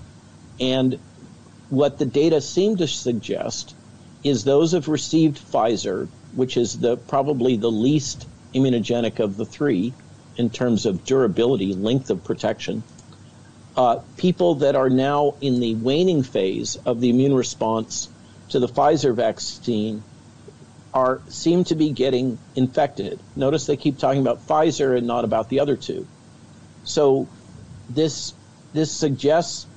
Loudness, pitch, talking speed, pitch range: -21 LUFS, 130 Hz, 135 wpm, 120-150 Hz